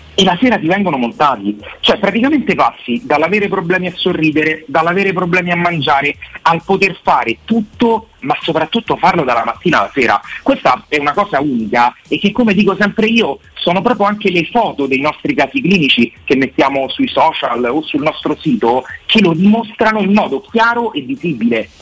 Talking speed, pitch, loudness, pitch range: 175 wpm, 185 Hz, -13 LUFS, 150-220 Hz